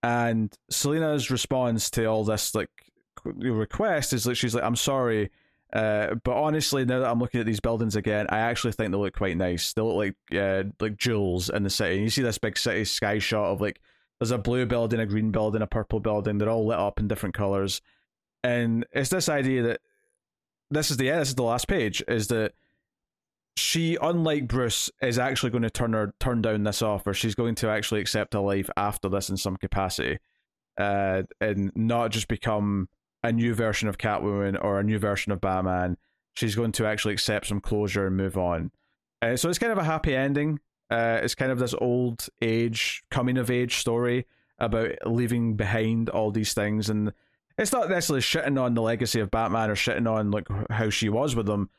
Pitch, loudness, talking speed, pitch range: 115 Hz, -26 LUFS, 210 wpm, 105-125 Hz